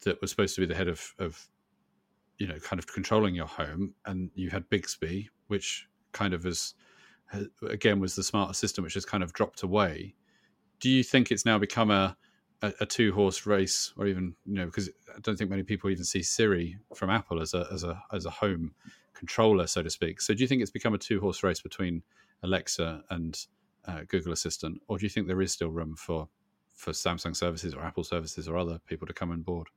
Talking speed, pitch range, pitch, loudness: 225 wpm, 85-105 Hz, 95 Hz, -30 LUFS